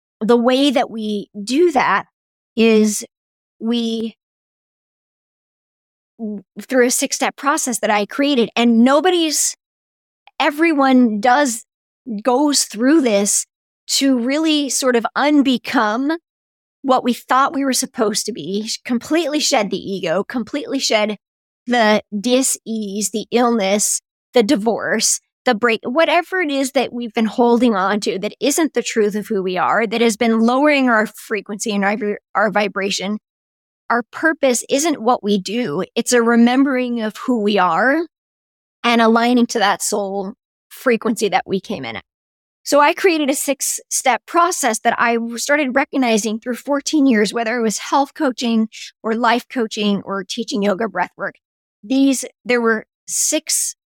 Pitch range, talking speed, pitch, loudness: 215-275 Hz, 150 wpm, 235 Hz, -17 LUFS